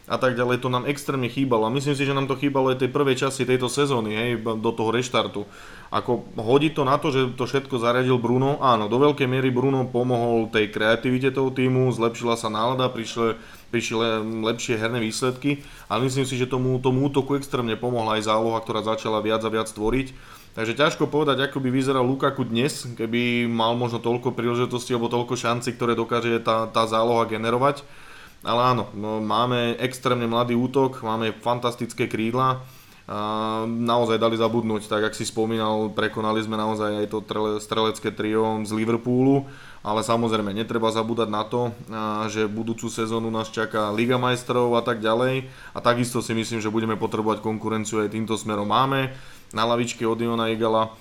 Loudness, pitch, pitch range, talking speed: -23 LUFS, 115 Hz, 110-130 Hz, 175 wpm